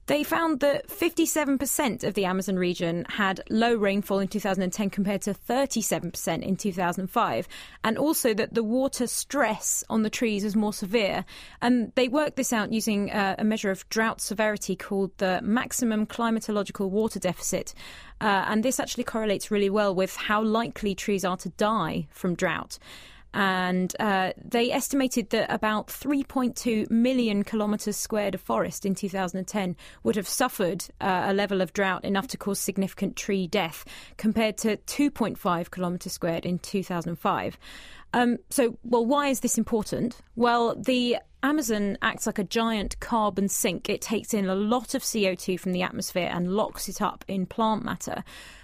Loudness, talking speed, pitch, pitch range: -27 LUFS, 160 wpm, 210 Hz, 195-235 Hz